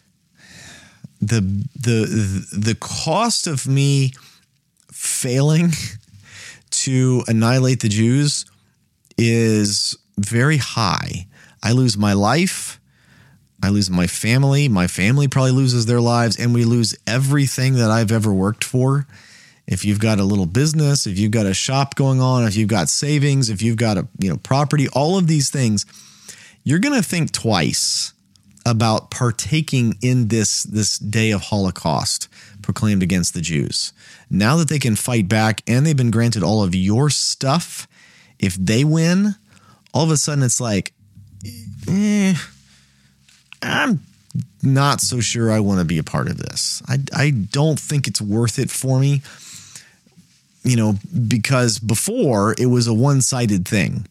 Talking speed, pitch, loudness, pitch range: 150 wpm, 115 Hz, -18 LUFS, 105-135 Hz